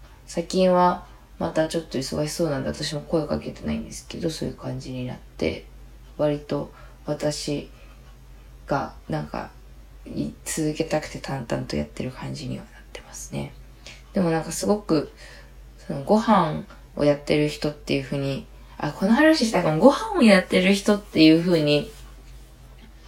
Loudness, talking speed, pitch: -23 LUFS, 305 characters per minute, 150 Hz